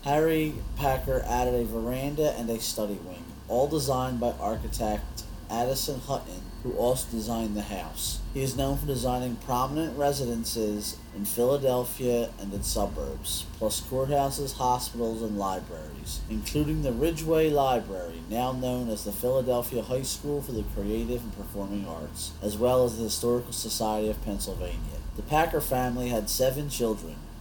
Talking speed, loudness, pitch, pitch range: 150 wpm, -29 LUFS, 120 Hz, 105-130 Hz